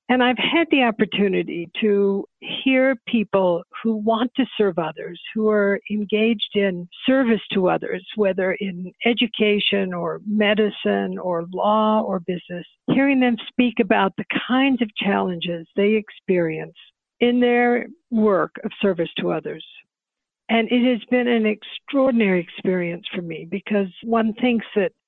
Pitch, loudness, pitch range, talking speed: 215 Hz, -21 LUFS, 190-240 Hz, 140 wpm